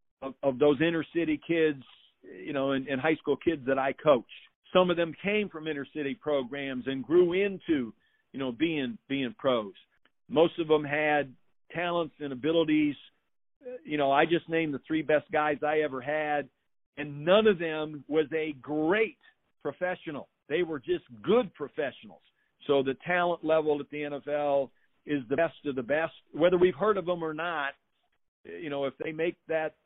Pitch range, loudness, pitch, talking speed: 140-170 Hz, -29 LUFS, 155 Hz, 180 wpm